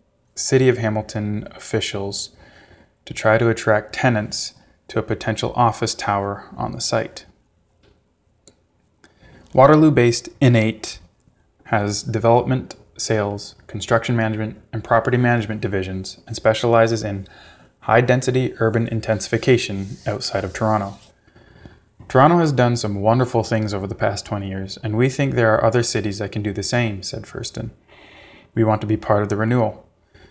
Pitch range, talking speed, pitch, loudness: 100-120 Hz, 145 wpm, 110 Hz, -20 LUFS